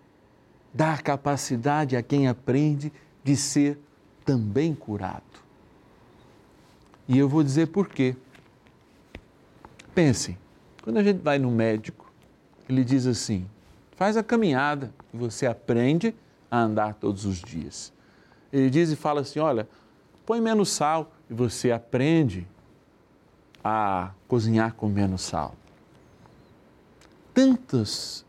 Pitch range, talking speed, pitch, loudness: 110-150 Hz, 115 wpm, 130 Hz, -25 LUFS